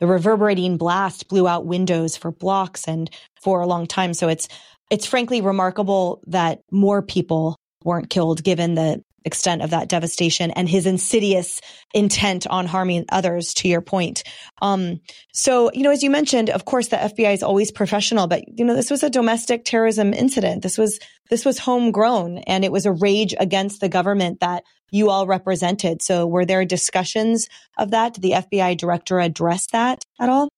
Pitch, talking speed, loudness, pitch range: 190 Hz, 180 wpm, -20 LUFS, 175-215 Hz